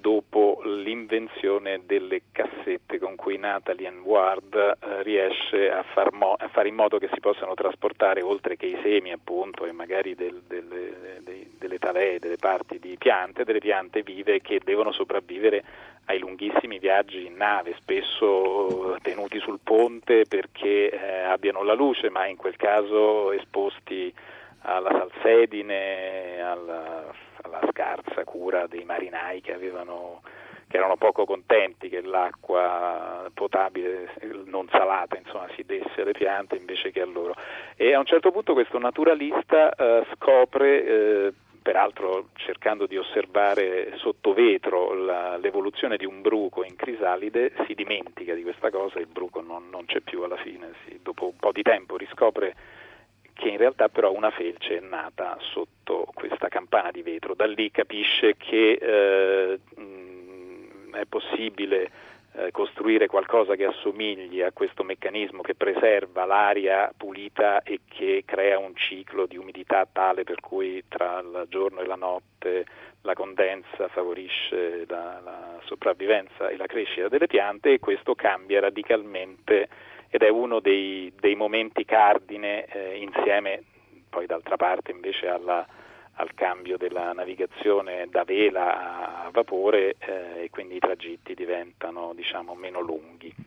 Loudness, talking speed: -25 LUFS, 145 wpm